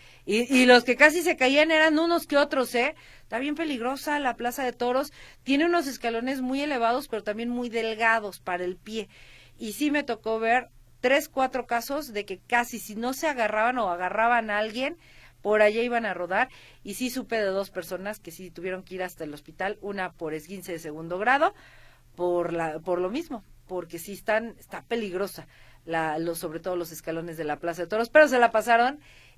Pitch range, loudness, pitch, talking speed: 180-255 Hz, -26 LUFS, 225 Hz, 205 wpm